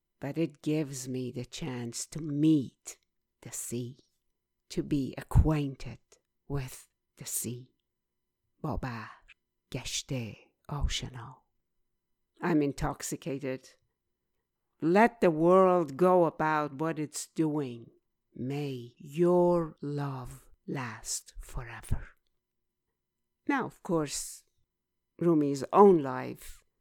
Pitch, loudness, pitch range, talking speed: 145 Hz, -30 LUFS, 130-165 Hz, 90 wpm